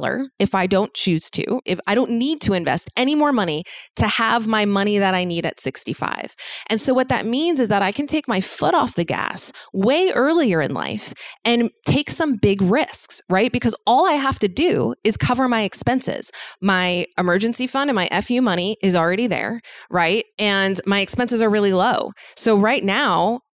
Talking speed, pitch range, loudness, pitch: 200 wpm, 195-250 Hz, -19 LUFS, 220 Hz